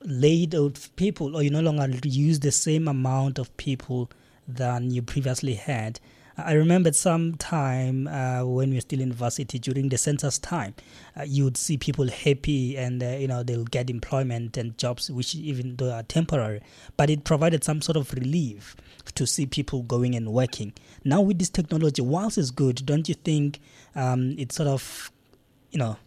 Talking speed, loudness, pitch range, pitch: 185 wpm, -25 LUFS, 125-150 Hz, 135 Hz